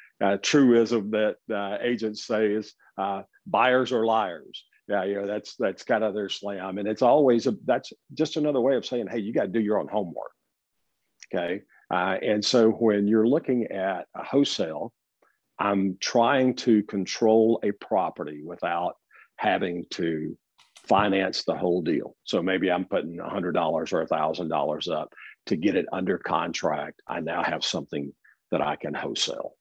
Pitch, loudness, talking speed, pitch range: 110 Hz, -26 LUFS, 165 wpm, 100-115 Hz